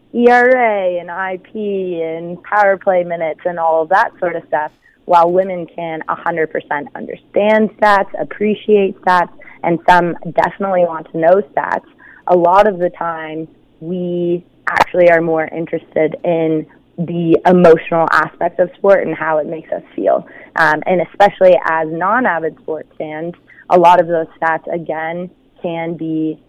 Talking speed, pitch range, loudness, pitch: 150 wpm, 160-185 Hz, -14 LUFS, 170 Hz